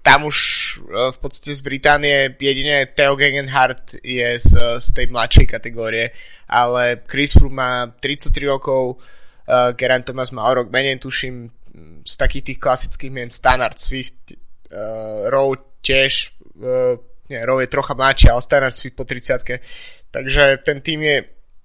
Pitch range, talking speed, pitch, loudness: 120-135 Hz, 150 wpm, 130 Hz, -17 LUFS